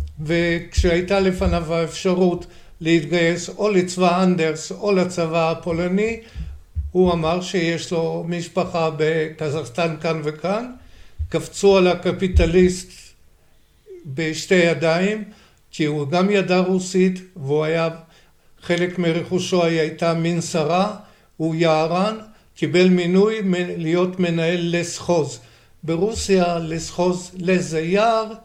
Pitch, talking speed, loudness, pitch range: 175 Hz, 95 wpm, -20 LUFS, 165-185 Hz